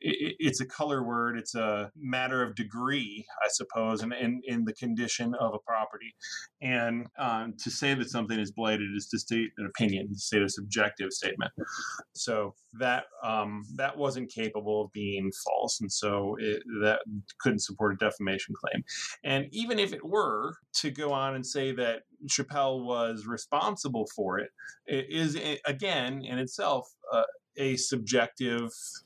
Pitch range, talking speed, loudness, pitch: 105-135 Hz, 160 wpm, -31 LUFS, 120 Hz